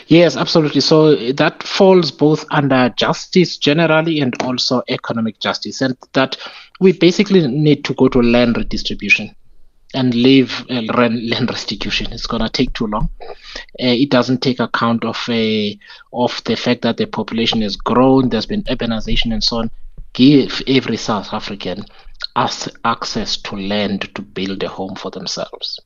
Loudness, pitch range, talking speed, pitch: -16 LUFS, 115-150 Hz, 160 wpm, 130 Hz